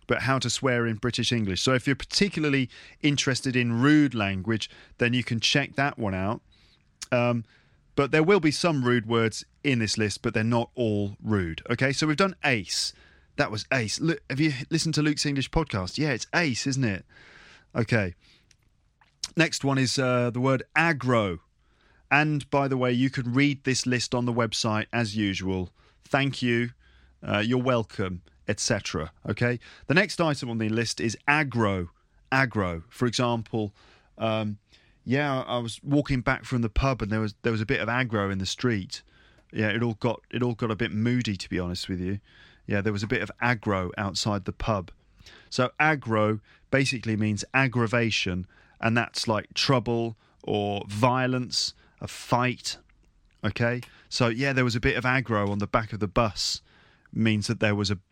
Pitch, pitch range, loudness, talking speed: 120 Hz, 105-135 Hz, -26 LUFS, 185 wpm